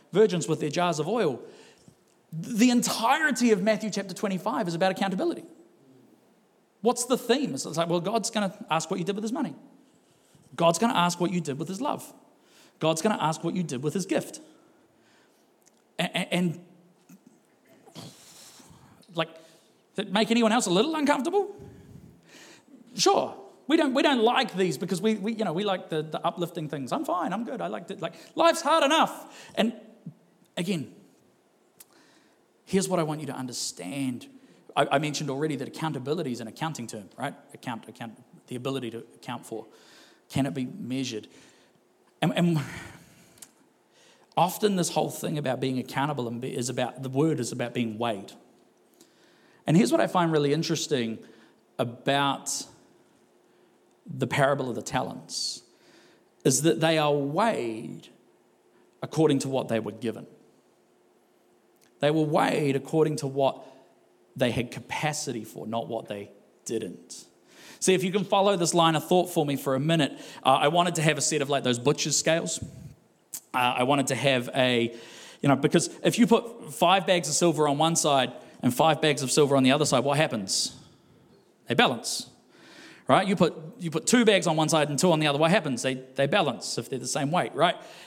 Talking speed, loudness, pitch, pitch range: 180 wpm, -26 LUFS, 160 Hz, 135-195 Hz